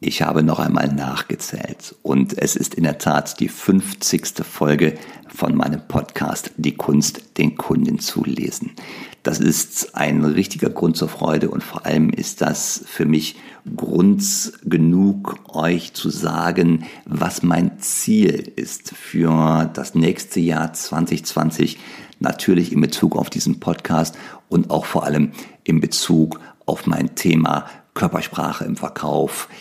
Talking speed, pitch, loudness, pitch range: 140 wpm, 80 Hz, -19 LUFS, 75-100 Hz